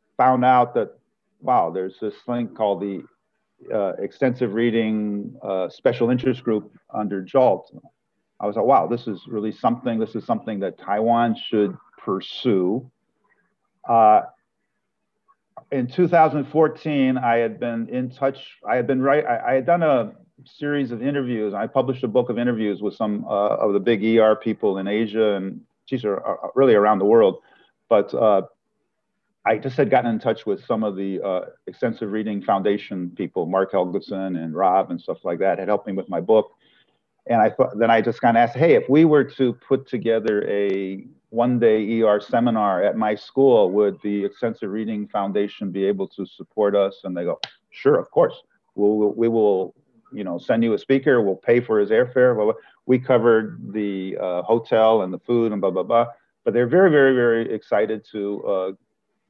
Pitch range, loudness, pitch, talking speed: 105-135 Hz, -21 LUFS, 115 Hz, 185 wpm